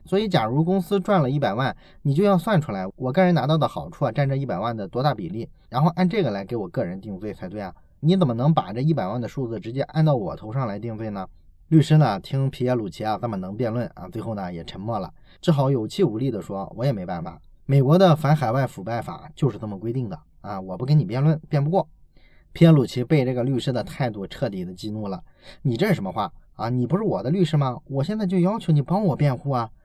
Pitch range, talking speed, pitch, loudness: 115-165 Hz, 360 characters per minute, 140 Hz, -23 LUFS